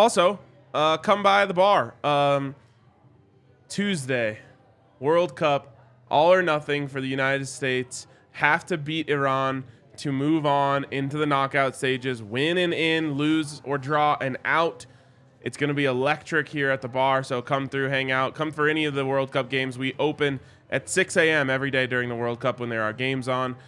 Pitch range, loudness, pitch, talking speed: 130-150 Hz, -24 LUFS, 135 Hz, 190 wpm